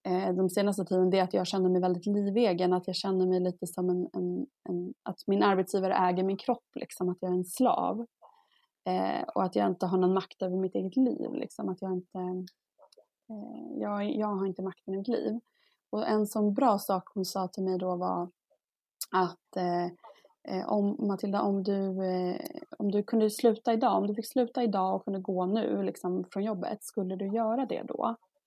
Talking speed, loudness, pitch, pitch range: 205 wpm, -30 LUFS, 195 Hz, 185-220 Hz